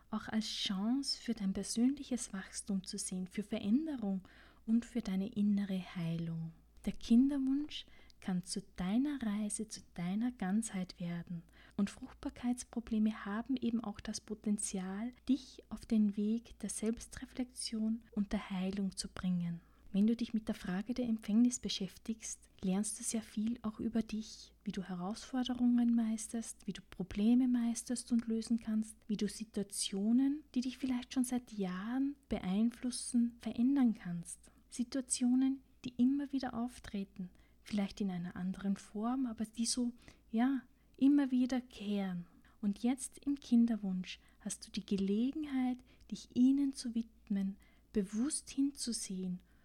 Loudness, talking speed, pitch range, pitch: -37 LUFS, 140 wpm, 200-245 Hz, 225 Hz